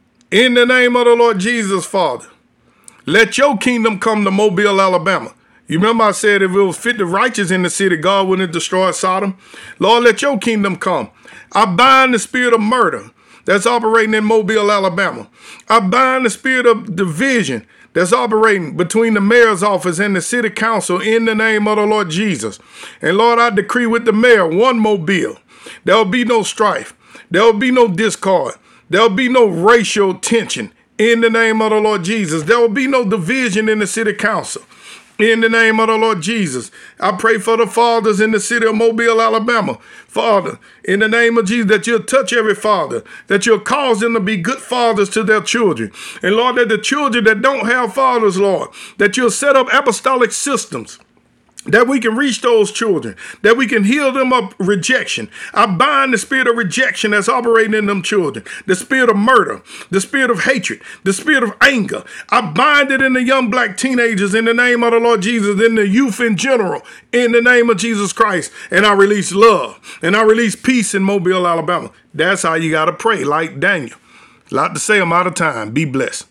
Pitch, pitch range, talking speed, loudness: 225 Hz, 200-235 Hz, 200 wpm, -13 LUFS